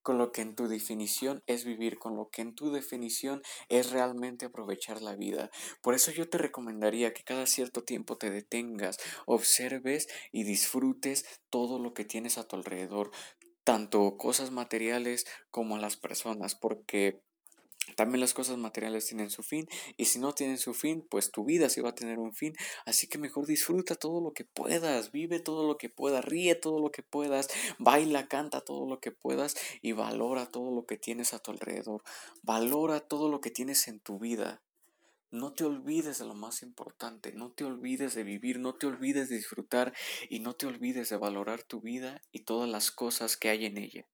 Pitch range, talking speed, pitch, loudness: 110-140 Hz, 195 wpm, 125 Hz, -33 LUFS